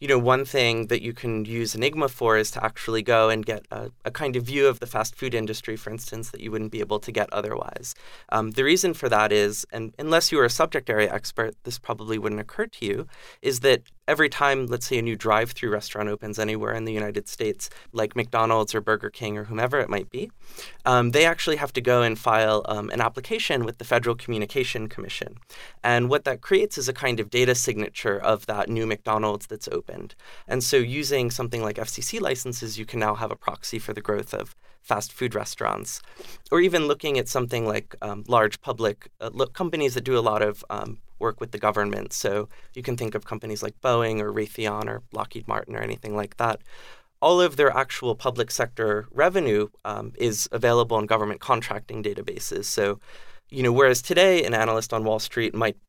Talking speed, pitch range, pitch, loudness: 215 wpm, 110-130 Hz, 115 Hz, -24 LUFS